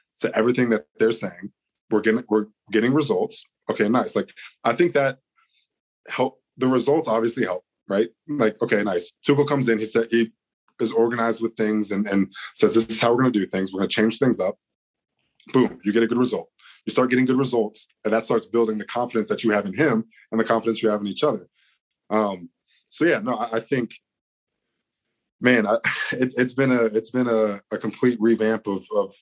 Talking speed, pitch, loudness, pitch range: 210 wpm, 115 Hz, -22 LUFS, 110-125 Hz